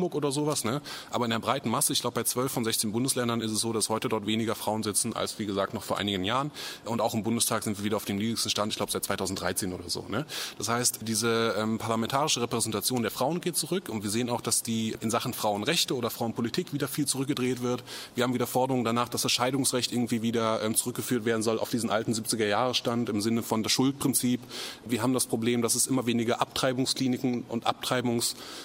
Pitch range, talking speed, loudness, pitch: 110-125 Hz, 225 wpm, -28 LUFS, 120 Hz